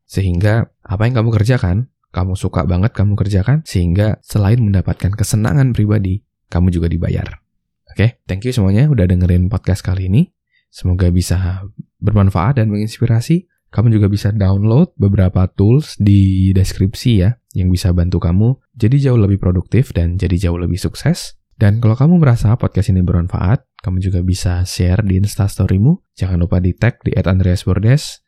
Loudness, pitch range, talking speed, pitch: -15 LUFS, 90-115 Hz, 155 wpm, 100 Hz